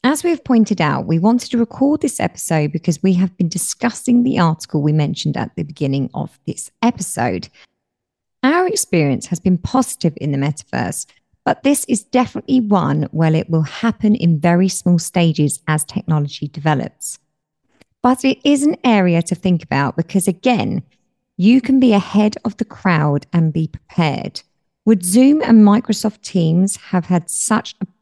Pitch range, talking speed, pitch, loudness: 160-235 Hz, 170 wpm, 185 Hz, -16 LUFS